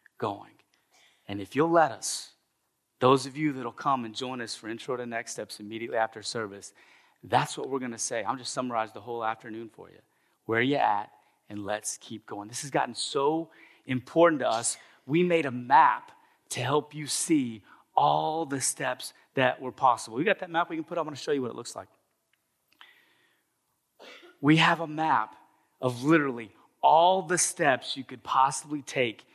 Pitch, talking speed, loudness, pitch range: 130 Hz, 195 wpm, -28 LUFS, 115-155 Hz